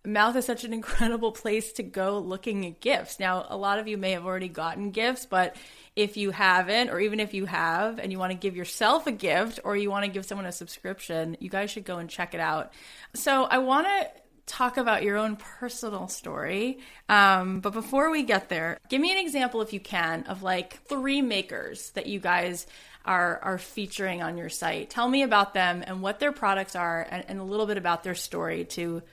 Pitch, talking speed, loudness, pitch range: 200 Hz, 220 wpm, -27 LUFS, 185-230 Hz